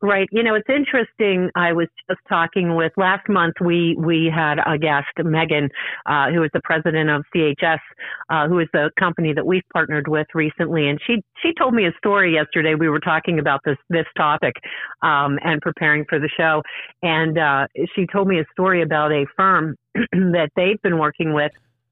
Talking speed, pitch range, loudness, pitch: 195 wpm, 155-185 Hz, -19 LUFS, 165 Hz